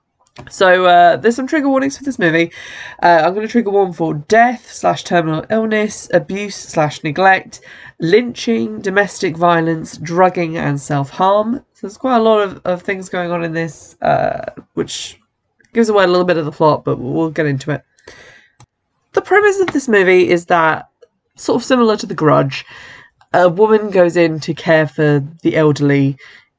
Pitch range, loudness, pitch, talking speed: 165-220 Hz, -14 LUFS, 180 Hz, 180 wpm